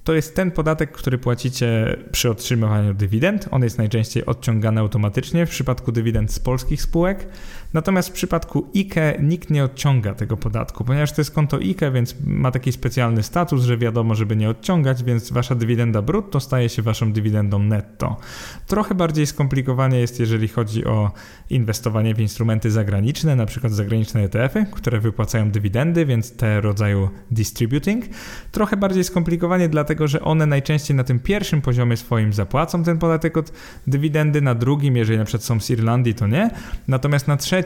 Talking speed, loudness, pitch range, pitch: 165 wpm, -20 LUFS, 110-155 Hz, 125 Hz